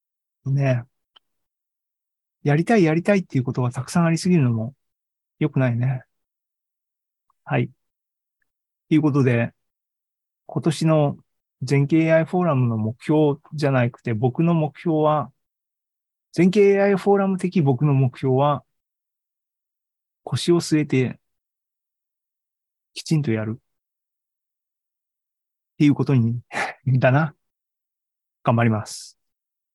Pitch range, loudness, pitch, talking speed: 125-160 Hz, -21 LUFS, 140 Hz, 210 characters per minute